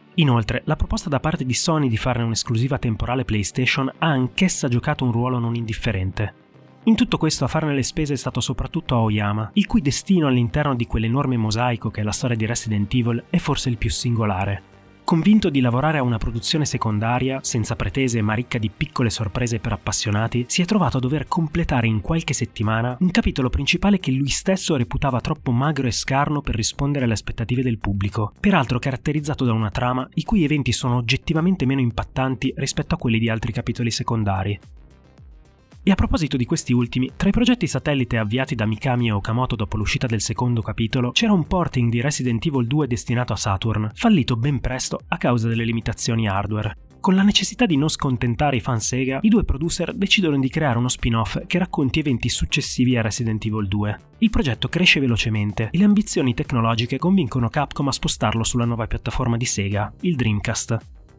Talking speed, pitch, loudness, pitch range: 190 wpm, 125 Hz, -21 LUFS, 115-150 Hz